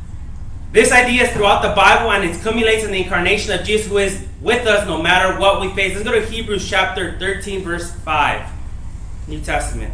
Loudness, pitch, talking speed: -16 LUFS, 195 Hz, 200 wpm